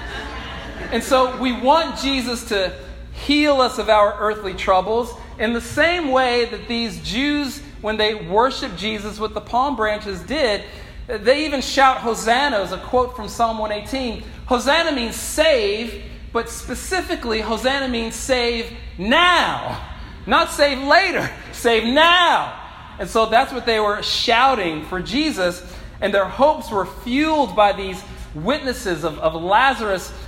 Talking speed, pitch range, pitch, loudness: 140 wpm, 210-270 Hz, 235 Hz, -19 LUFS